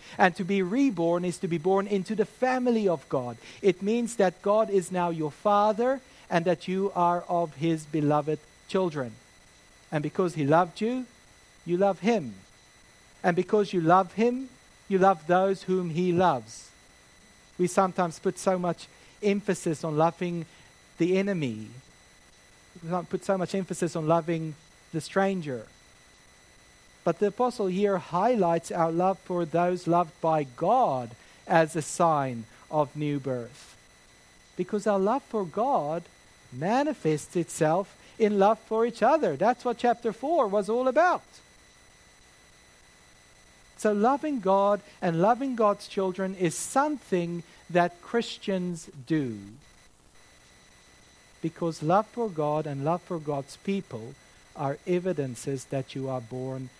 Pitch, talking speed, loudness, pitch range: 175 Hz, 140 wpm, -27 LUFS, 150-200 Hz